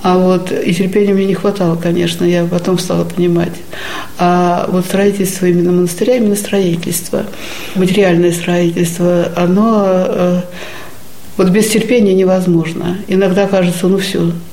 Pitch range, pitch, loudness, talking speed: 175-195 Hz, 180 Hz, -13 LUFS, 125 wpm